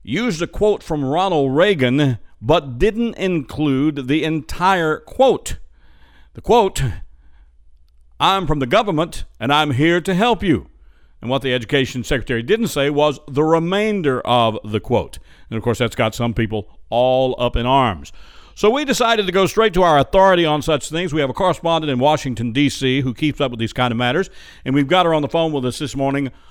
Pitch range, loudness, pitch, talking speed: 120-165 Hz, -18 LUFS, 140 Hz, 195 wpm